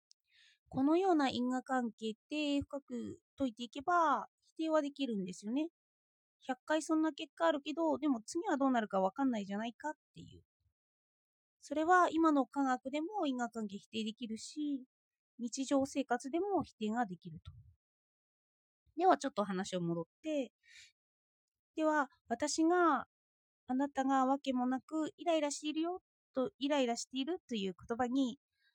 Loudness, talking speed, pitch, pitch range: -36 LUFS, 300 characters per minute, 270 Hz, 230-310 Hz